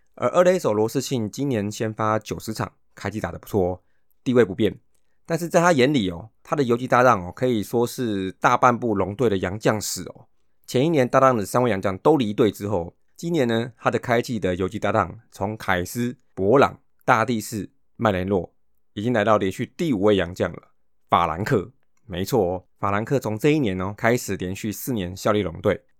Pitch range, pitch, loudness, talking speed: 100-125 Hz, 110 Hz, -22 LUFS, 295 characters per minute